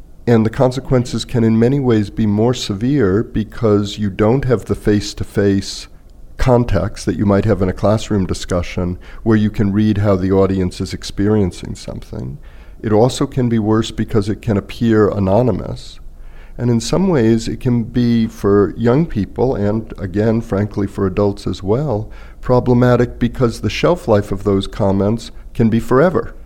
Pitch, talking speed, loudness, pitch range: 105 Hz, 170 wpm, -16 LUFS, 100-115 Hz